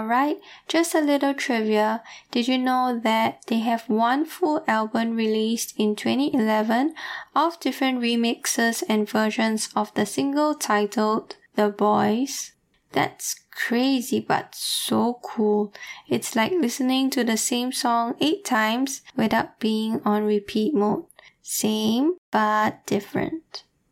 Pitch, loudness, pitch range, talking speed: 235 Hz, -23 LUFS, 220-275 Hz, 125 wpm